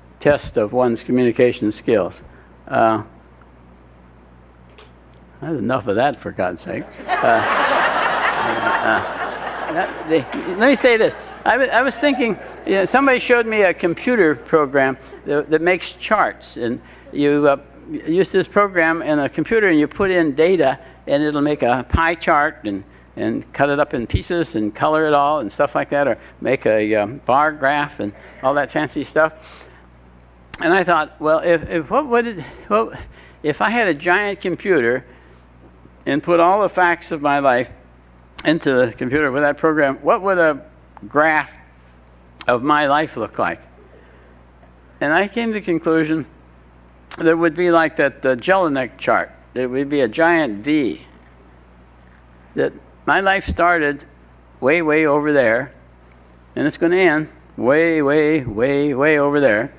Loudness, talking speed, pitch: -18 LUFS, 170 wpm, 145 Hz